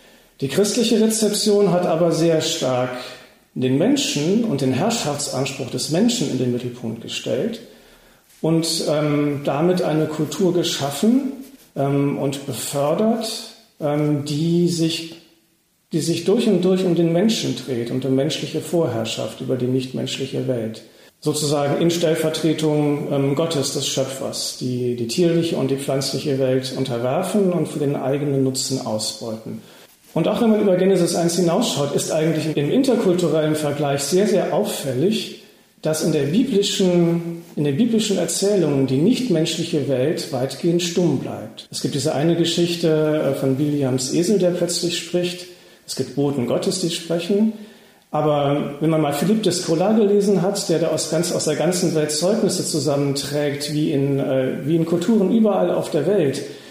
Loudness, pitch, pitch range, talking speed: -20 LUFS, 160 Hz, 140-180 Hz, 150 wpm